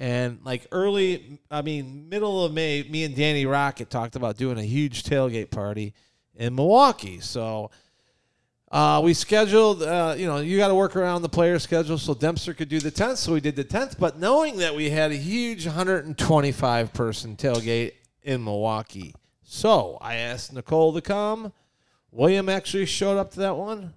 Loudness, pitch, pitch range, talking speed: -24 LUFS, 150 Hz, 120-180 Hz, 180 wpm